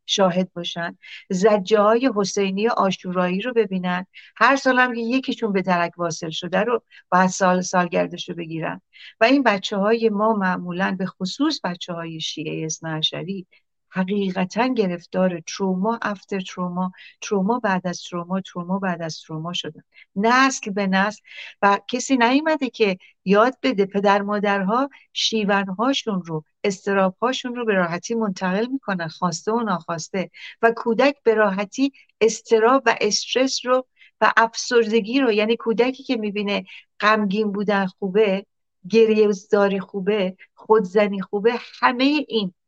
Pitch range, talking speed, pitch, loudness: 185-230 Hz, 130 wpm, 205 Hz, -21 LUFS